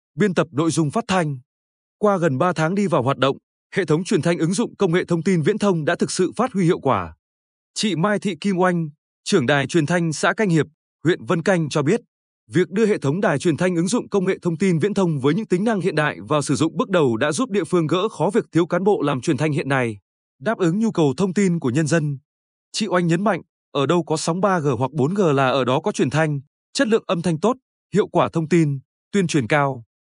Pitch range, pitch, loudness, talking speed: 150-200 Hz, 170 Hz, -20 LUFS, 255 wpm